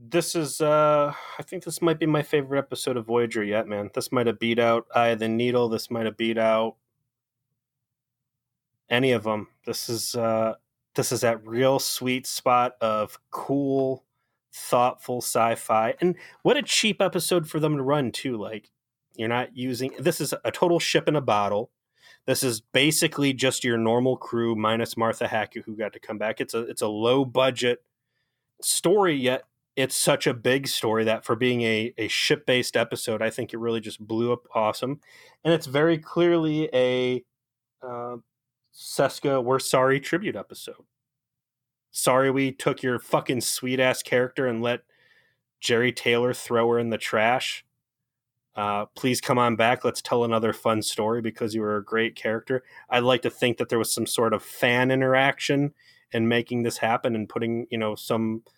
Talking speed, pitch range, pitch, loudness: 180 wpm, 115-135 Hz, 125 Hz, -24 LUFS